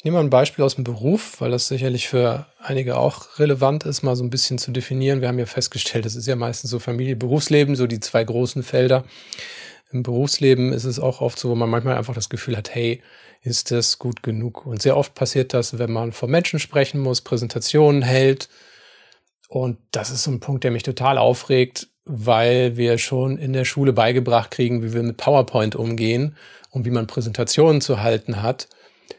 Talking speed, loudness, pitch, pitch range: 205 wpm, -20 LUFS, 125 Hz, 120-135 Hz